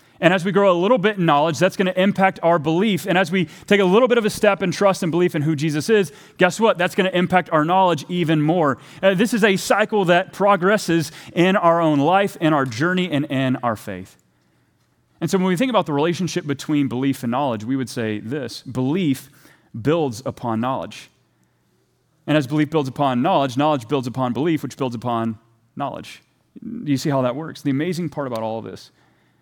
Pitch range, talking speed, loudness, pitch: 135-185 Hz, 220 wpm, -19 LUFS, 155 Hz